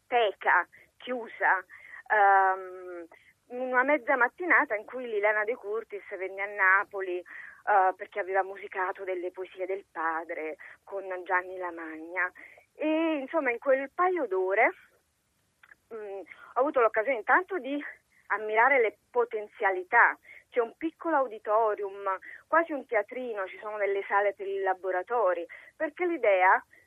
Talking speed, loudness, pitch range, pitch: 125 wpm, -28 LUFS, 190-265 Hz, 210 Hz